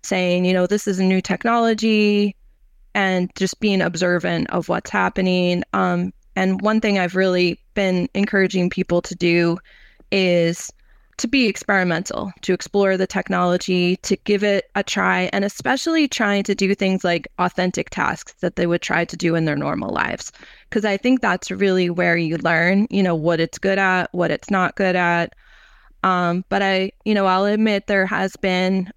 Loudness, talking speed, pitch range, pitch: -19 LUFS, 180 wpm, 180-200 Hz, 190 Hz